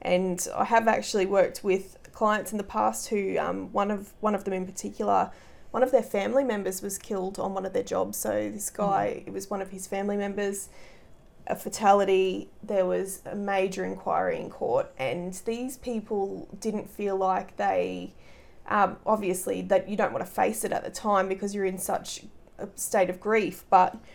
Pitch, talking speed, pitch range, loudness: 195 Hz, 195 wpm, 190-215 Hz, -28 LUFS